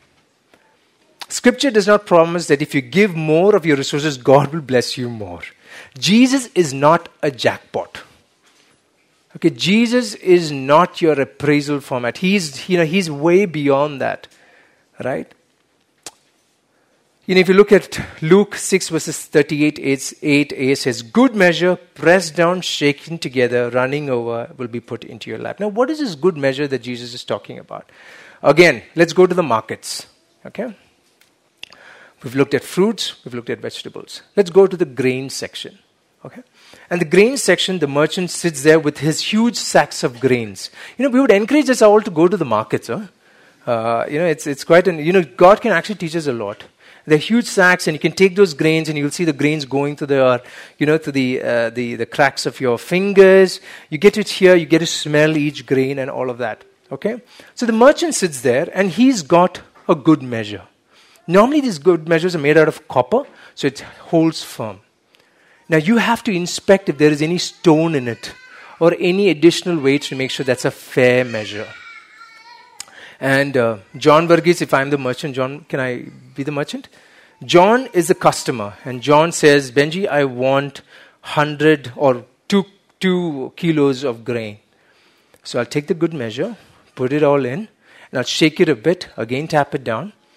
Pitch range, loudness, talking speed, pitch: 135-185 Hz, -16 LUFS, 190 wpm, 160 Hz